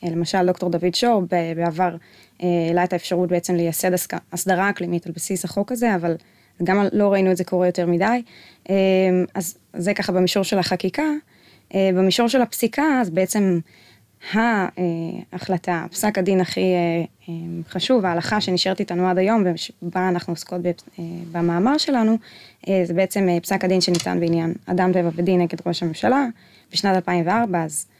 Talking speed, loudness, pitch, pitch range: 165 wpm, -21 LUFS, 185 Hz, 175-195 Hz